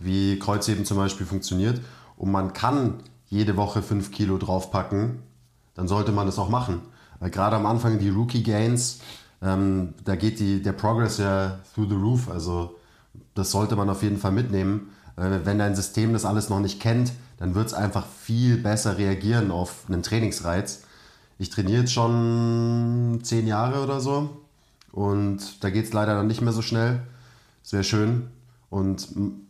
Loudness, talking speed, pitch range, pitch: -25 LUFS, 170 wpm, 100-115 Hz, 105 Hz